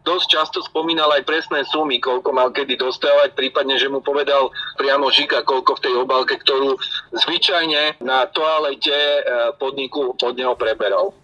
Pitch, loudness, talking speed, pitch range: 145 Hz, -18 LUFS, 150 wpm, 130-155 Hz